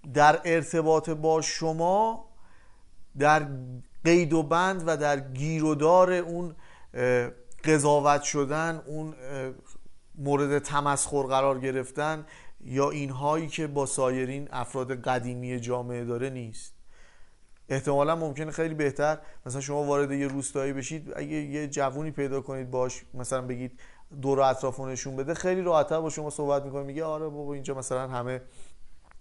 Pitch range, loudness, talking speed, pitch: 130-155 Hz, -28 LUFS, 130 wpm, 140 Hz